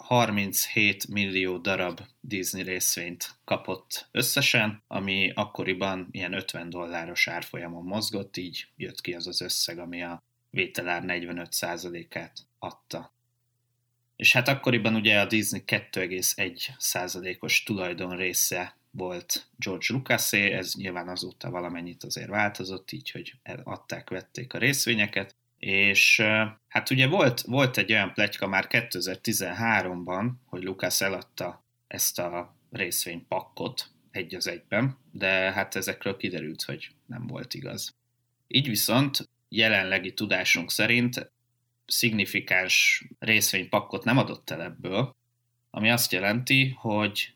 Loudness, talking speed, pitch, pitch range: -26 LUFS, 115 wpm, 105 Hz, 90-120 Hz